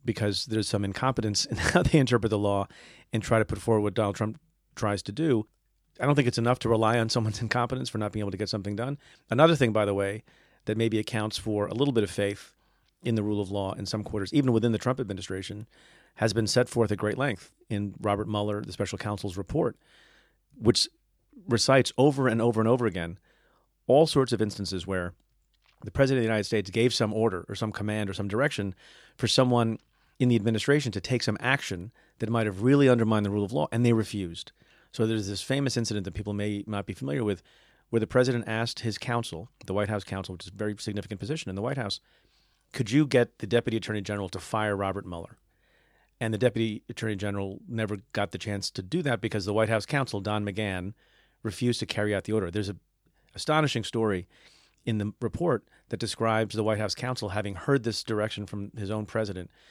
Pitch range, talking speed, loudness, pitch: 100-120 Hz, 220 wpm, -28 LUFS, 110 Hz